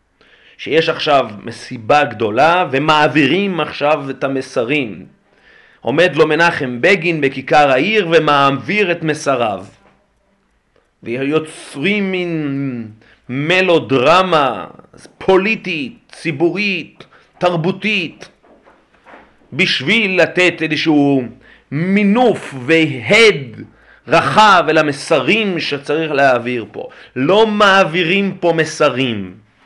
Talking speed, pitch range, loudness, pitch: 75 wpm, 135-180 Hz, -14 LUFS, 155 Hz